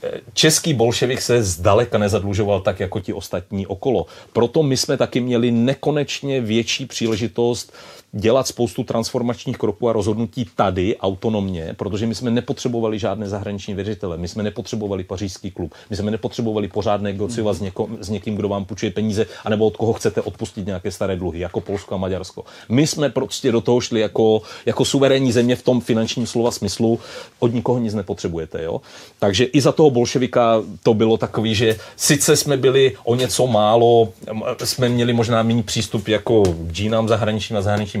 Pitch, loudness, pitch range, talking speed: 115 Hz, -19 LUFS, 105-120 Hz, 170 wpm